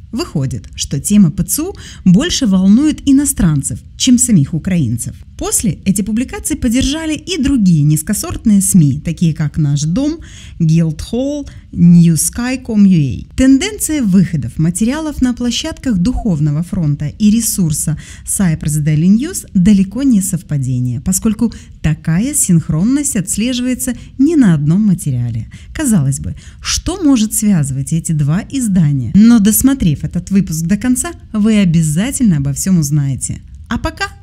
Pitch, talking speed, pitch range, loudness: 195 Hz, 120 wpm, 155-250 Hz, -13 LUFS